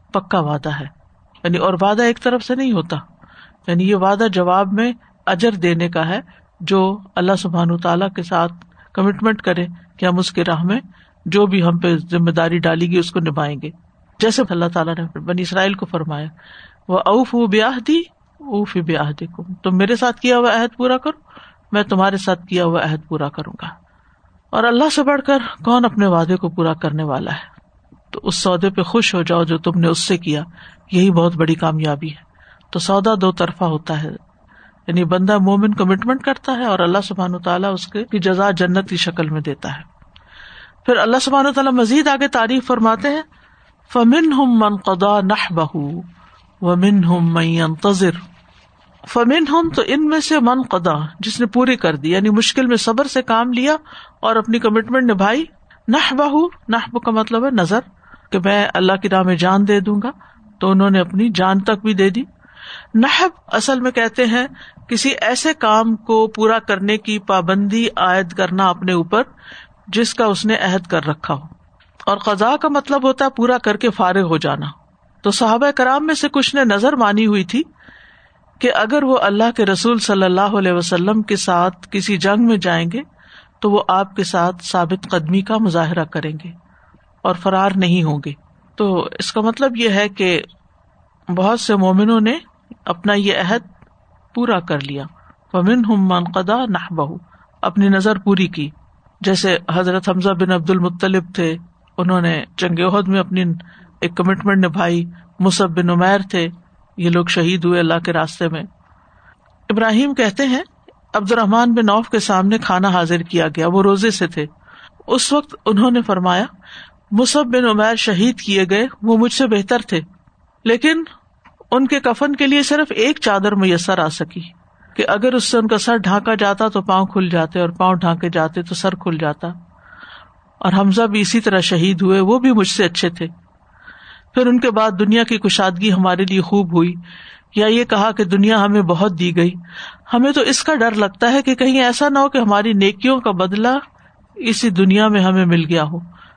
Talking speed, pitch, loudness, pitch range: 185 wpm, 195 Hz, -16 LUFS, 175-230 Hz